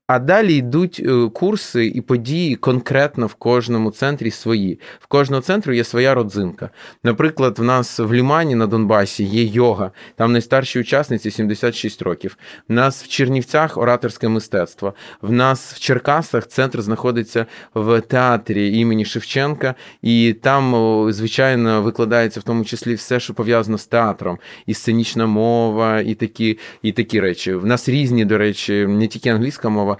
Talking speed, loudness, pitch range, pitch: 150 wpm, -17 LUFS, 110-130 Hz, 115 Hz